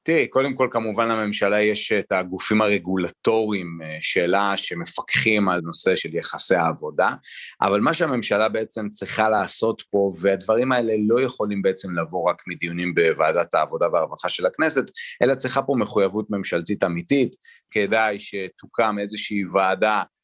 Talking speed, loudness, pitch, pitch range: 135 wpm, -22 LUFS, 105 Hz, 95-110 Hz